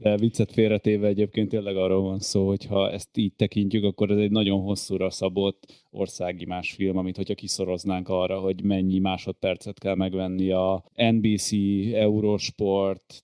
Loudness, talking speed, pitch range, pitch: -25 LUFS, 155 wpm, 95-105 Hz, 100 Hz